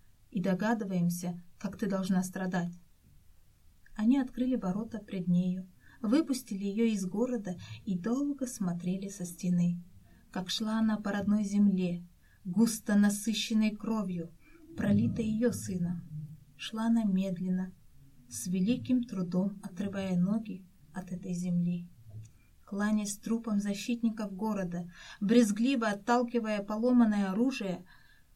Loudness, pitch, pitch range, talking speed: -32 LUFS, 200 Hz, 180-220 Hz, 110 wpm